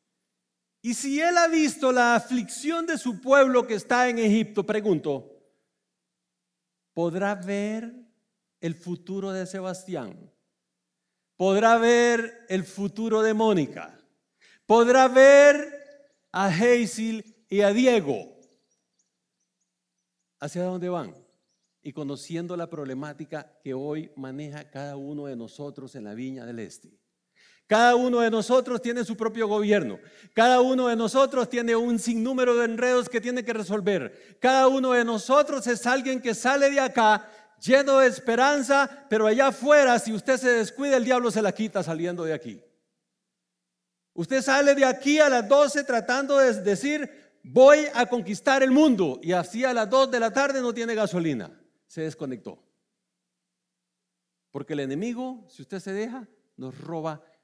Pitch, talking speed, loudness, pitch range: 225 Hz, 145 wpm, -23 LUFS, 170-255 Hz